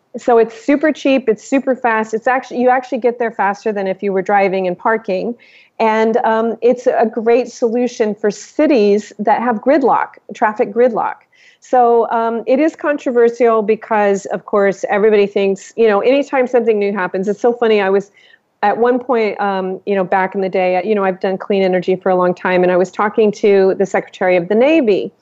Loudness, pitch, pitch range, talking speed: -15 LUFS, 220 Hz, 195-245 Hz, 200 wpm